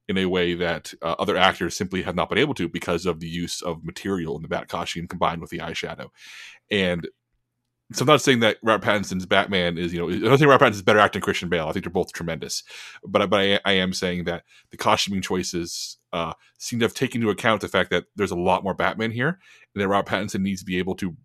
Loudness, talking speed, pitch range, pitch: -23 LUFS, 250 wpm, 85-105 Hz, 95 Hz